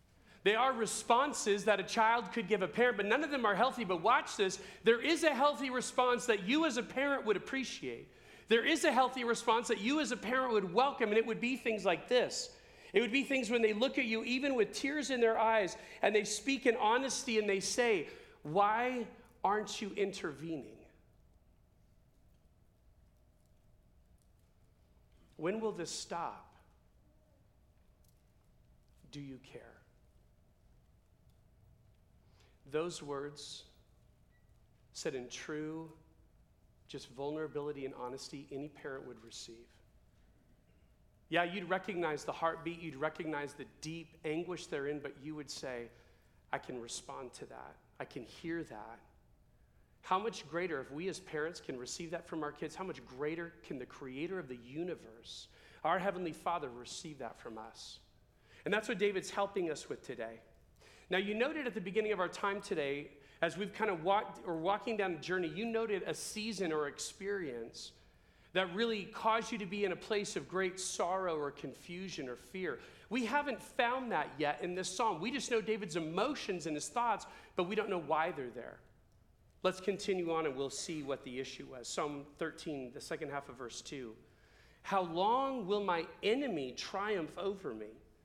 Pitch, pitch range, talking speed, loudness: 185 Hz, 150-225 Hz, 170 wpm, -36 LUFS